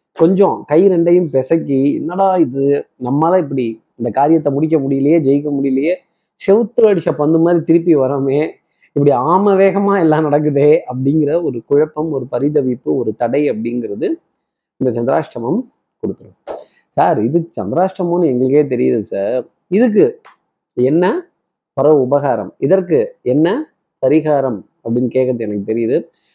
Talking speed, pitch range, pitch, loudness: 120 wpm, 135-180 Hz, 150 Hz, -15 LUFS